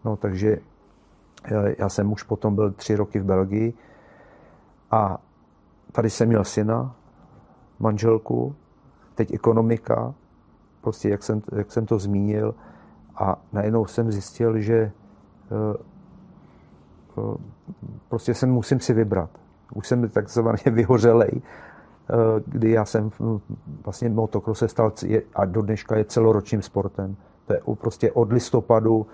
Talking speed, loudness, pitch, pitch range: 115 wpm, -23 LUFS, 110 Hz, 100-115 Hz